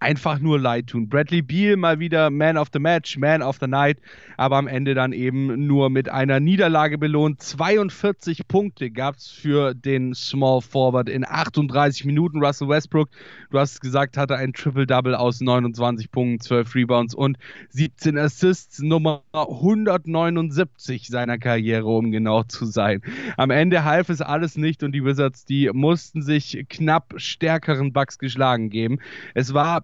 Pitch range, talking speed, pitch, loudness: 130-155 Hz, 160 wpm, 140 Hz, -21 LUFS